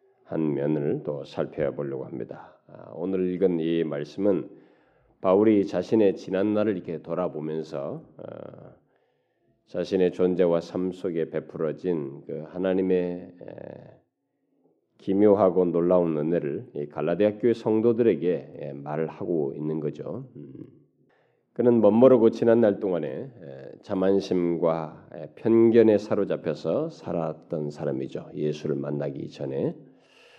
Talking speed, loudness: 240 characters per minute, -25 LUFS